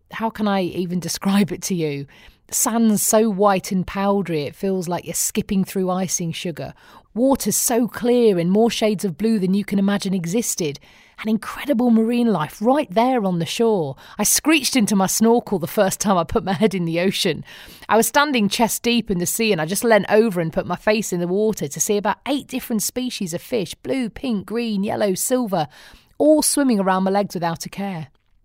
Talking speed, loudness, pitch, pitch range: 210 wpm, -20 LUFS, 205 Hz, 185-230 Hz